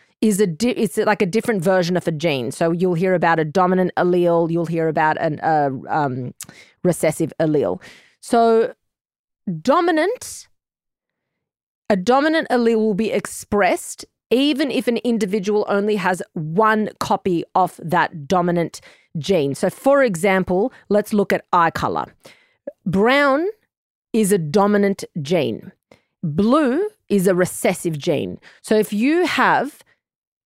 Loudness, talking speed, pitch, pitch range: -19 LUFS, 135 wpm, 200 Hz, 175-230 Hz